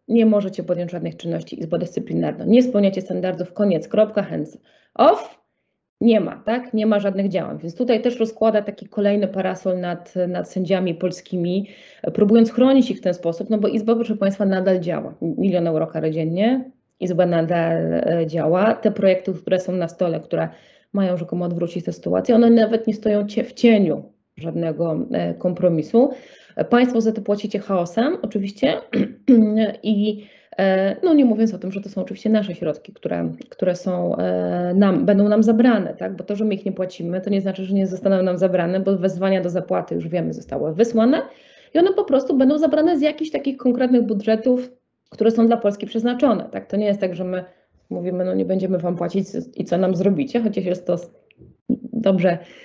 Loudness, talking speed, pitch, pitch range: -20 LUFS, 180 wpm, 195 Hz, 180-225 Hz